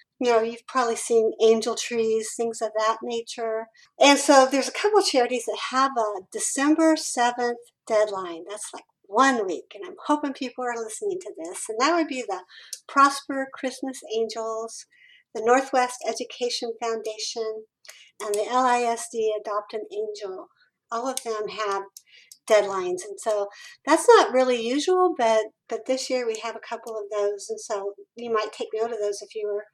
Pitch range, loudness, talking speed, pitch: 220-270 Hz, -24 LUFS, 175 wpm, 230 Hz